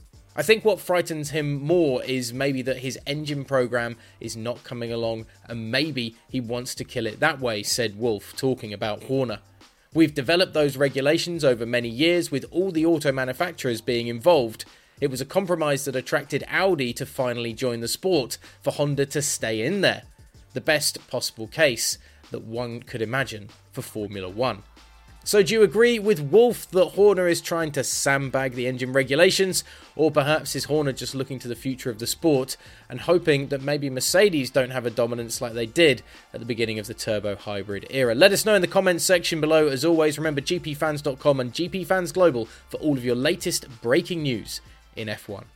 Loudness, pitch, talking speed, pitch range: -23 LUFS, 135 Hz, 190 wpm, 120-155 Hz